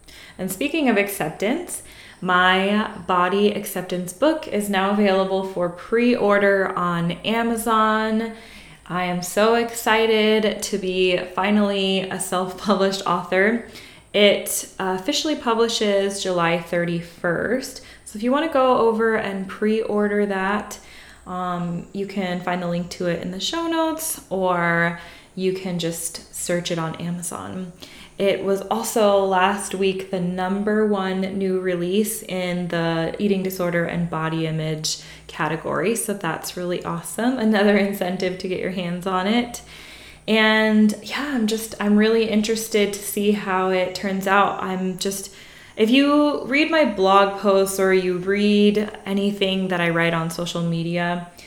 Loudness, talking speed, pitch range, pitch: -21 LUFS, 145 wpm, 180-215 Hz, 195 Hz